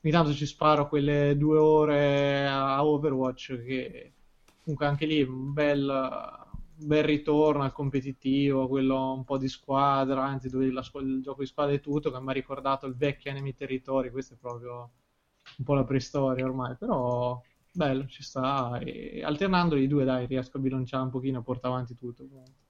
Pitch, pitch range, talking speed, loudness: 135 Hz, 130-145 Hz, 180 wpm, -28 LUFS